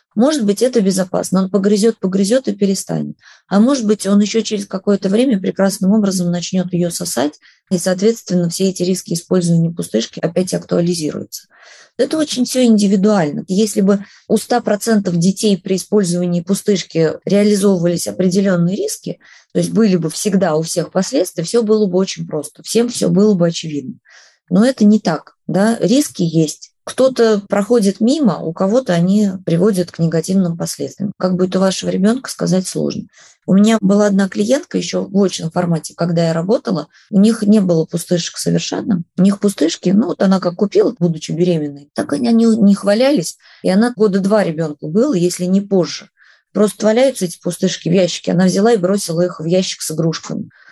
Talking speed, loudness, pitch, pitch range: 170 wpm, -15 LUFS, 195 Hz, 175-215 Hz